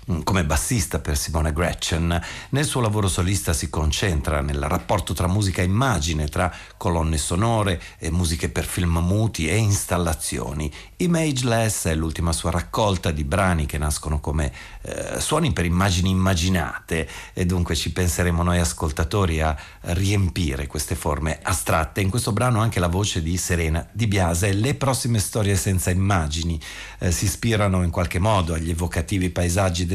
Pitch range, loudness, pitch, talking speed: 85-100 Hz, -22 LUFS, 90 Hz, 160 wpm